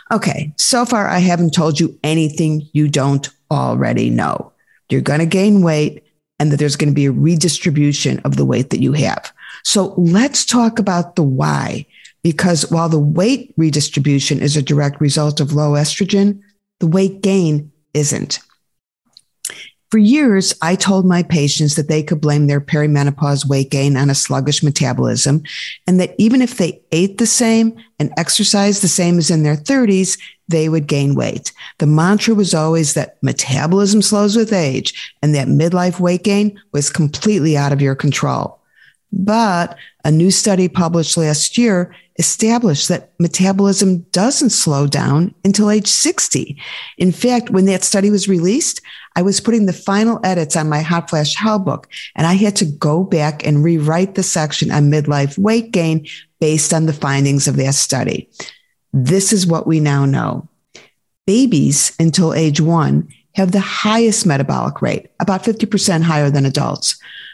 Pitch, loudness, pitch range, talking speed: 165 Hz, -15 LUFS, 150-195 Hz, 165 wpm